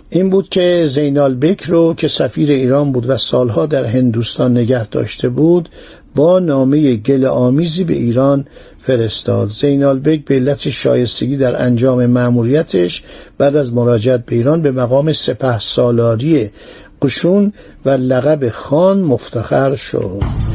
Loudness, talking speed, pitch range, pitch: -13 LUFS, 135 wpm, 120-155 Hz, 135 Hz